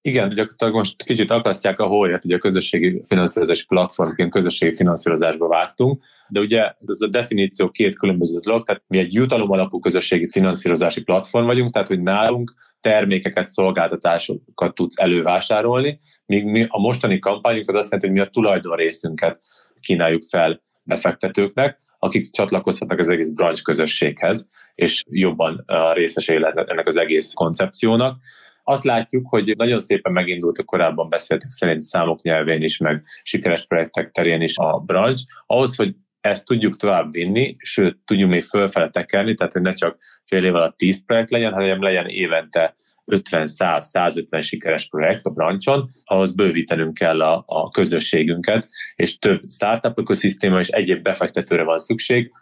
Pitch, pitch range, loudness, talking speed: 95 Hz, 85-115 Hz, -19 LUFS, 150 wpm